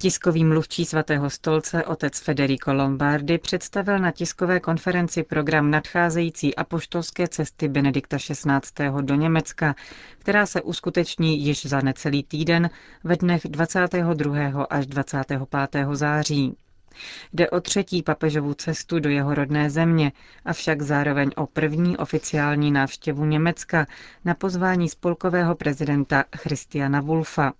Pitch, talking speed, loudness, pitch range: 155 Hz, 120 wpm, -23 LUFS, 145-170 Hz